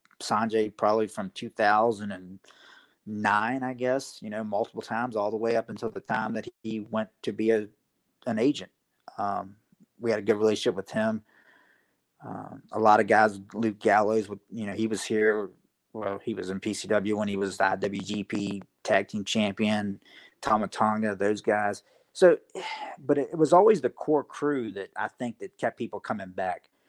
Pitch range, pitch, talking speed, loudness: 100-115 Hz, 110 Hz, 170 wpm, -27 LUFS